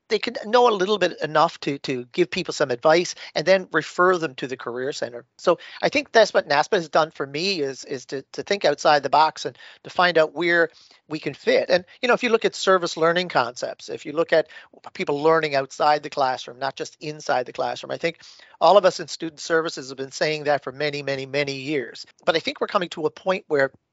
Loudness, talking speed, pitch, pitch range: -22 LUFS, 245 wpm, 160 Hz, 145-180 Hz